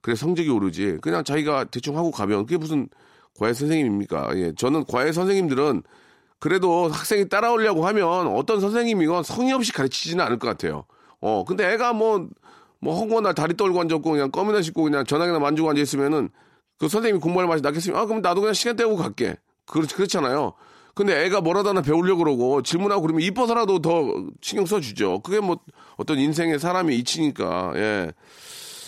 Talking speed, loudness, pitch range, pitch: 420 characters per minute, -22 LUFS, 155-210 Hz, 175 Hz